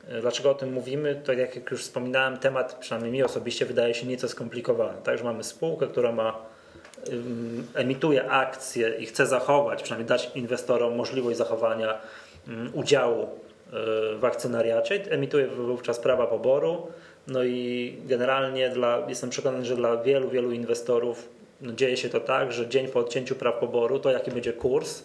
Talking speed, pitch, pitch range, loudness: 155 wpm, 125 Hz, 120-140 Hz, -27 LUFS